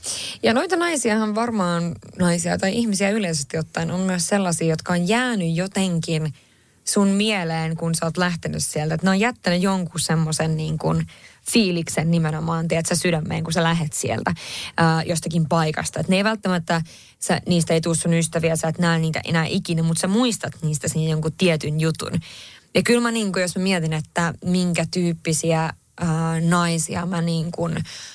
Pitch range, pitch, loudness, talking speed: 160-180 Hz, 170 Hz, -21 LUFS, 175 wpm